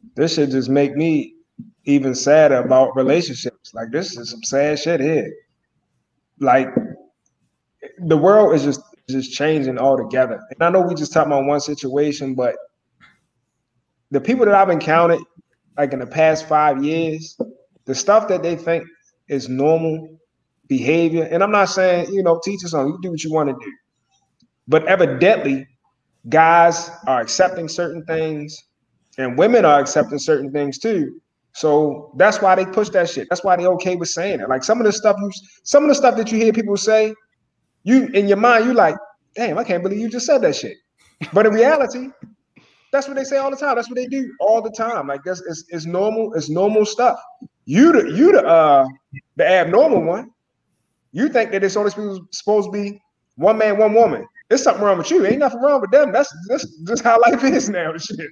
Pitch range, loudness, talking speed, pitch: 145-220 Hz, -17 LUFS, 195 wpm, 175 Hz